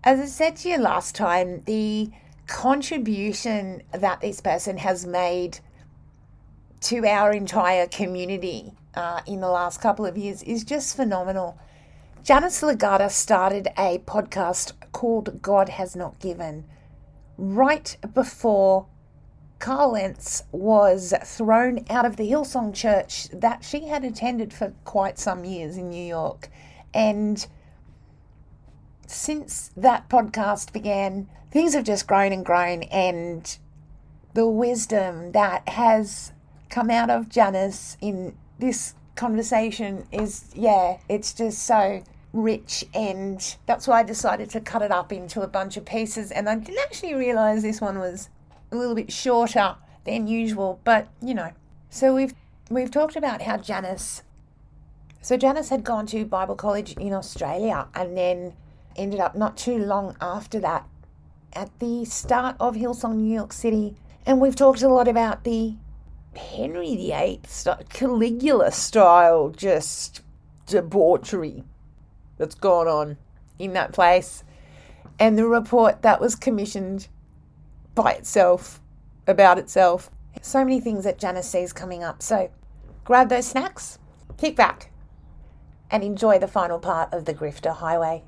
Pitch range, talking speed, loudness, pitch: 180-235 Hz, 140 wpm, -23 LUFS, 205 Hz